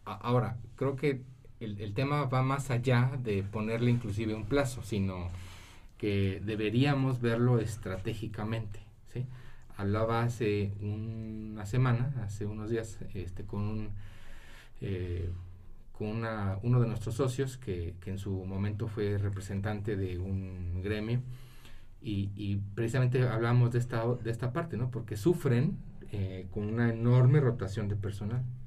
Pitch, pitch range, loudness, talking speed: 110 Hz, 100-120 Hz, -32 LUFS, 140 wpm